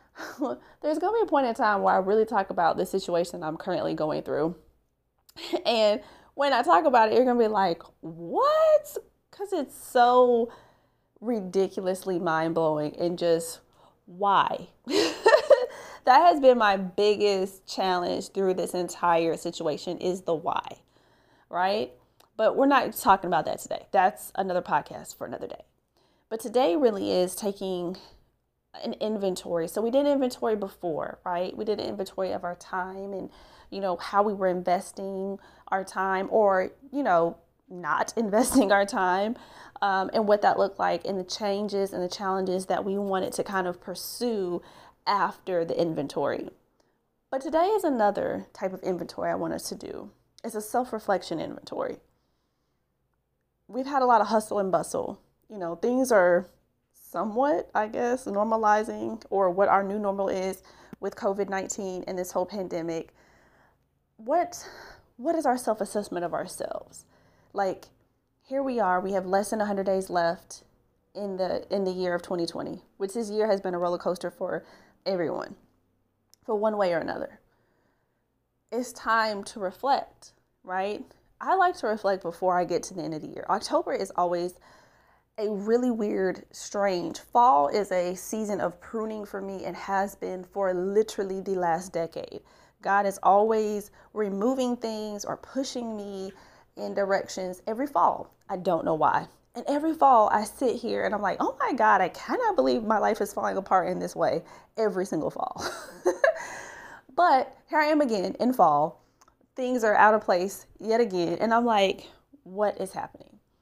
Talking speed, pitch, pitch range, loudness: 165 wpm, 195 Hz, 185-225 Hz, -26 LUFS